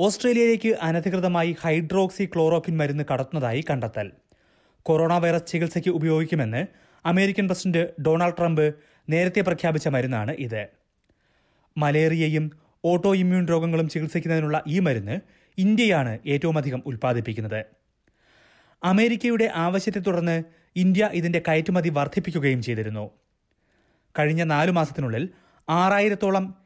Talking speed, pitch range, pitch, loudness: 95 wpm, 145-180 Hz, 165 Hz, -23 LUFS